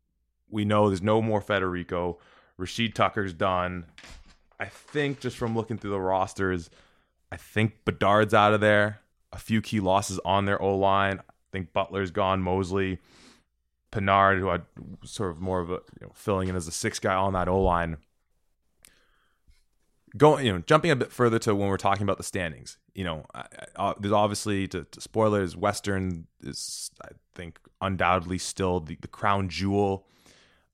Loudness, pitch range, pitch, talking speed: -26 LUFS, 90-105 Hz, 95 Hz, 175 wpm